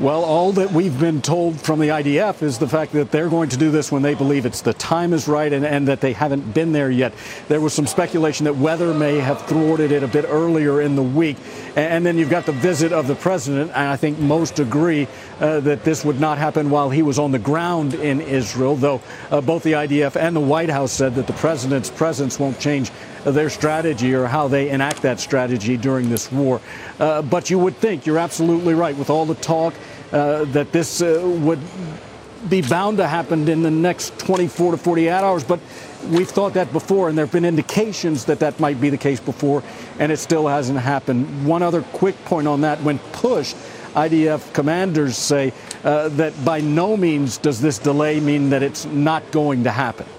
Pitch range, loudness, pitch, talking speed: 140-165 Hz, -19 LUFS, 150 Hz, 215 wpm